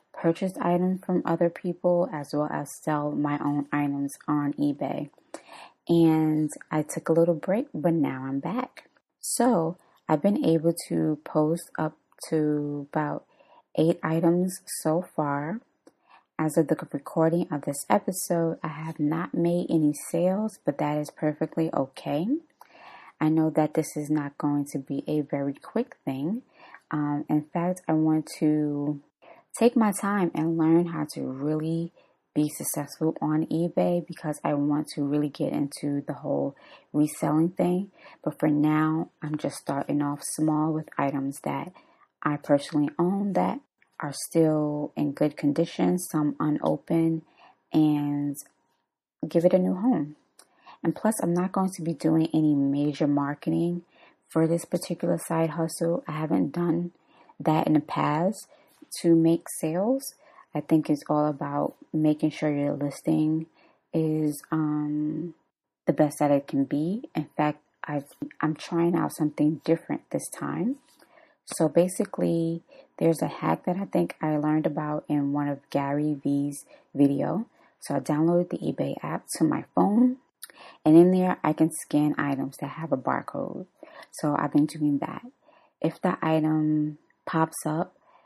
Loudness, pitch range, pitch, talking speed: -27 LUFS, 150-170 Hz, 155 Hz, 155 wpm